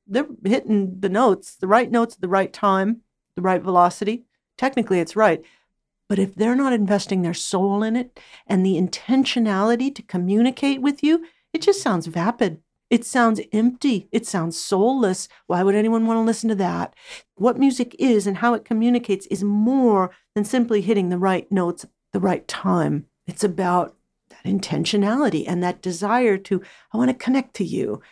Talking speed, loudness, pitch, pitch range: 180 wpm, -21 LUFS, 215 Hz, 190-240 Hz